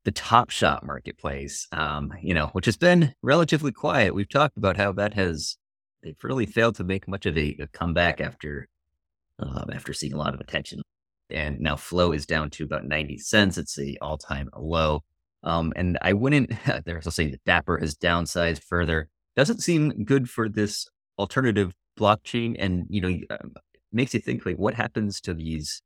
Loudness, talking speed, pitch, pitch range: -25 LUFS, 185 wpm, 85 Hz, 75-105 Hz